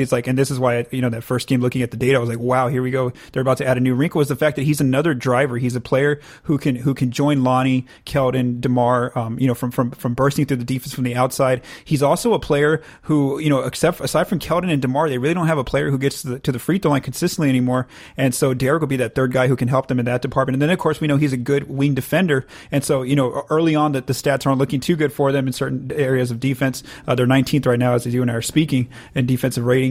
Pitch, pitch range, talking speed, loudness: 135 Hz, 125-145 Hz, 300 wpm, -19 LUFS